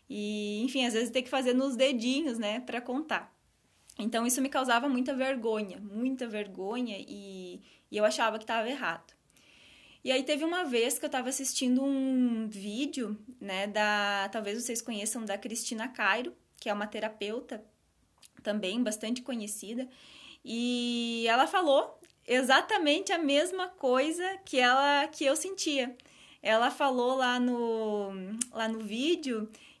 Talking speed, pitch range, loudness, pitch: 145 wpm, 220-270 Hz, -30 LUFS, 245 Hz